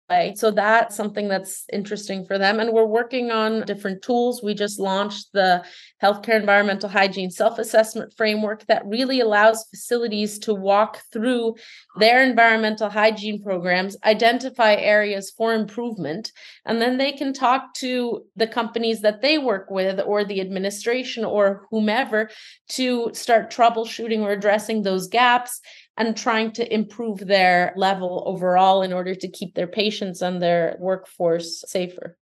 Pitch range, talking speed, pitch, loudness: 195-230 Hz, 145 wpm, 215 Hz, -21 LUFS